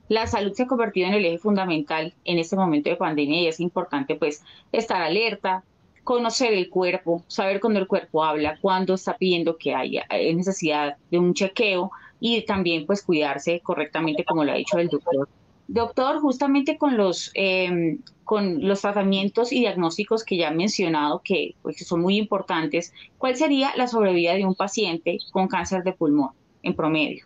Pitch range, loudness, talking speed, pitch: 160-205 Hz, -23 LUFS, 180 wpm, 185 Hz